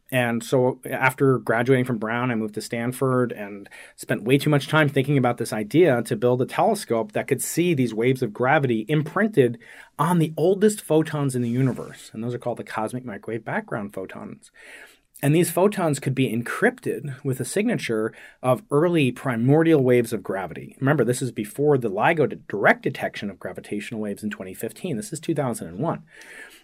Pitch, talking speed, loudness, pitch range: 130 Hz, 180 wpm, -23 LUFS, 120-150 Hz